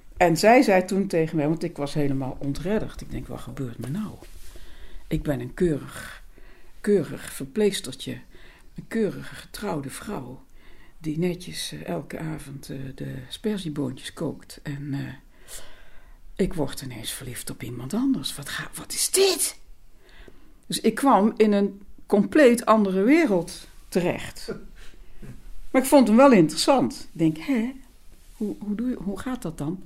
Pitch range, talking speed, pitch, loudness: 140-215 Hz, 150 wpm, 175 Hz, -24 LUFS